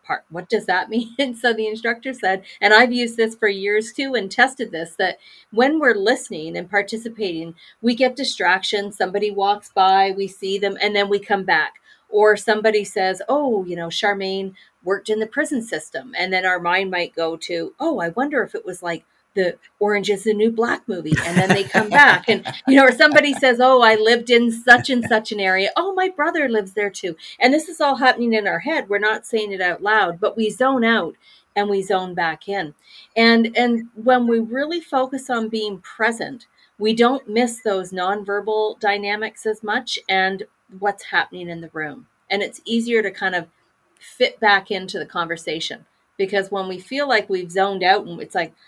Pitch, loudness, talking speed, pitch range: 215 Hz, -19 LUFS, 205 wpm, 195-240 Hz